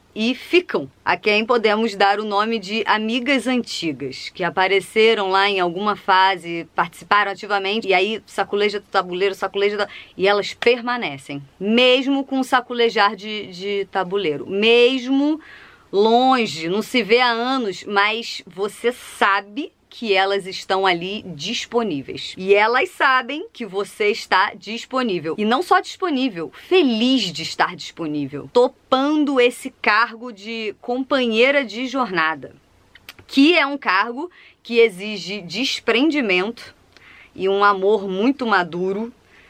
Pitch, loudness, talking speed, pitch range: 215 Hz, -19 LUFS, 130 wpm, 195-250 Hz